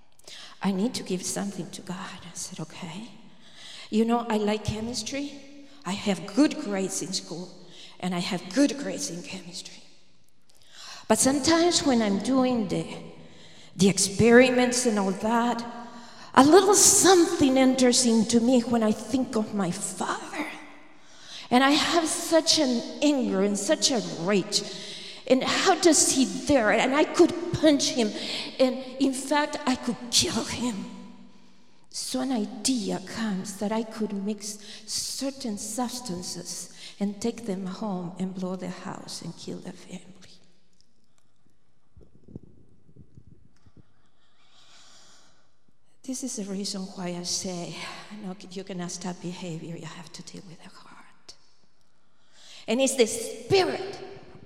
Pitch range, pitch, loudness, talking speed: 190-260 Hz, 220 Hz, -25 LUFS, 135 wpm